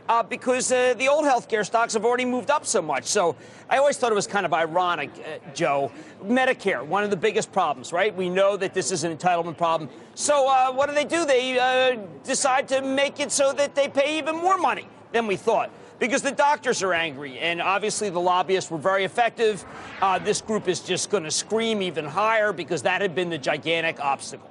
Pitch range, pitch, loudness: 180-260 Hz, 215 Hz, -23 LUFS